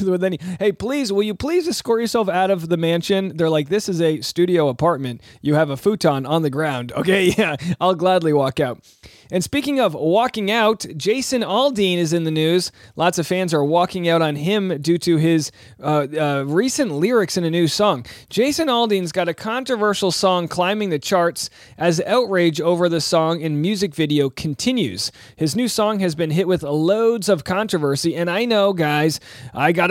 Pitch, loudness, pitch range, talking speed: 175 Hz, -19 LUFS, 155-200 Hz, 195 wpm